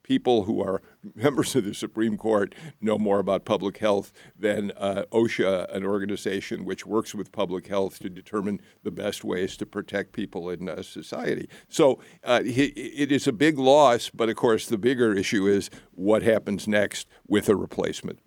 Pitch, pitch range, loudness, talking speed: 105 Hz, 100-115 Hz, -25 LUFS, 180 wpm